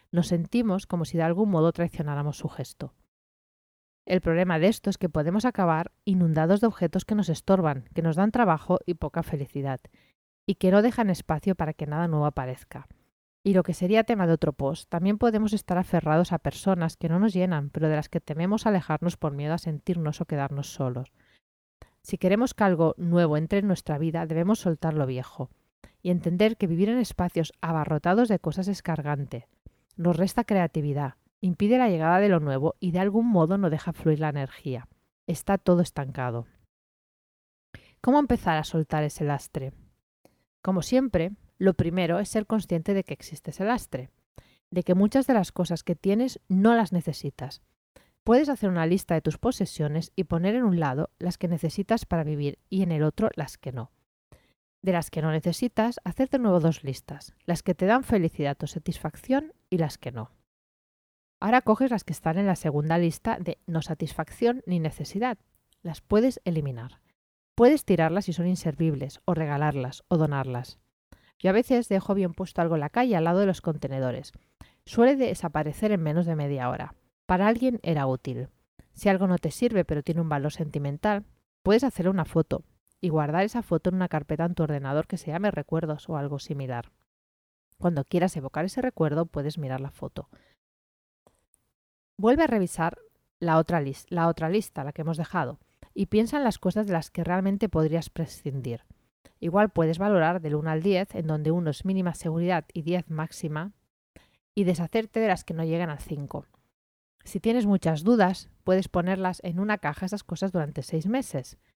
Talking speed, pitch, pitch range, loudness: 185 wpm, 170 Hz, 155-195 Hz, -26 LUFS